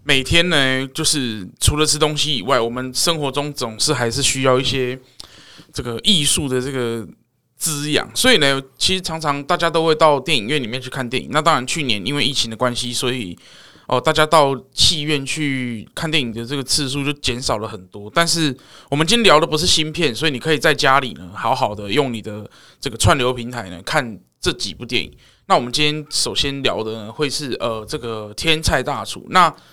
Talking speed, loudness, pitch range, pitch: 305 characters per minute, -18 LUFS, 125-155 Hz, 135 Hz